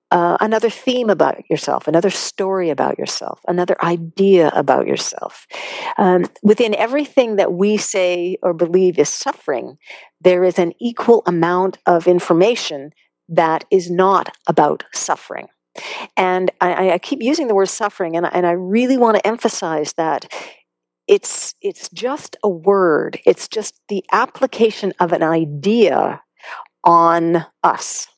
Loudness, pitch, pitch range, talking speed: -17 LUFS, 185 Hz, 175-220 Hz, 140 wpm